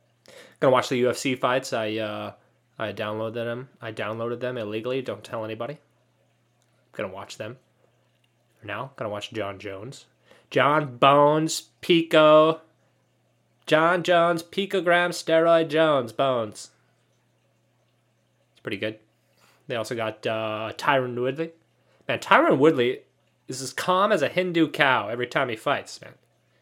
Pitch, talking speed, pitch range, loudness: 125 Hz, 140 wpm, 110-160 Hz, -23 LUFS